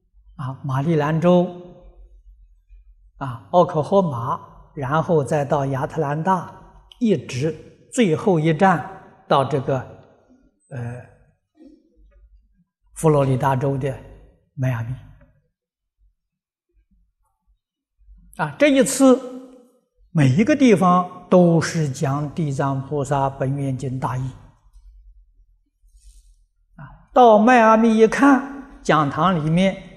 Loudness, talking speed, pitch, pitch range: -19 LUFS, 140 characters per minute, 155 Hz, 130-190 Hz